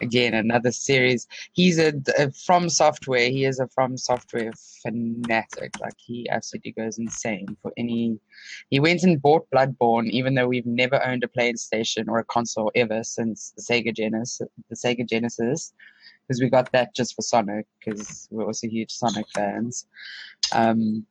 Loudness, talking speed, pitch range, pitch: -23 LUFS, 165 wpm, 115-125 Hz, 120 Hz